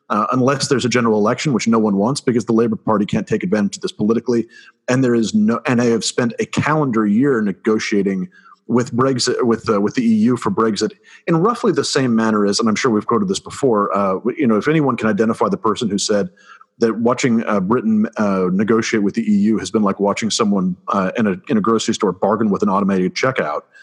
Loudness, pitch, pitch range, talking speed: -17 LUFS, 115 Hz, 105-130 Hz, 230 wpm